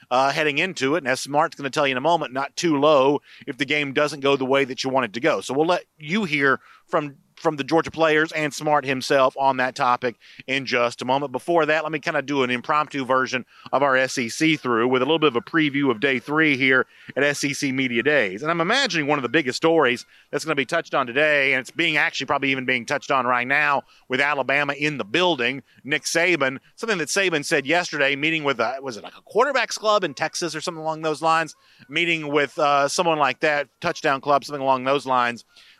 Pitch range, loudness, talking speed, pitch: 130-160 Hz, -21 LUFS, 245 wpm, 145 Hz